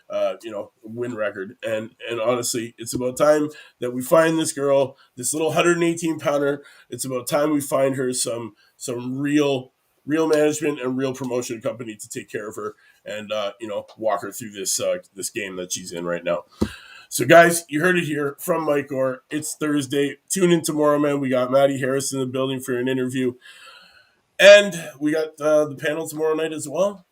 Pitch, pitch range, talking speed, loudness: 145 Hz, 130-160 Hz, 200 wpm, -21 LUFS